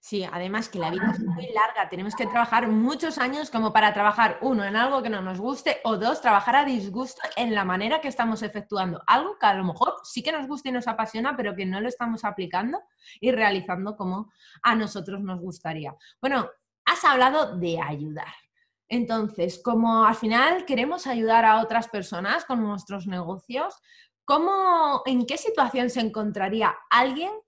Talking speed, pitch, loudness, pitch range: 180 wpm, 225 Hz, -24 LUFS, 200-260 Hz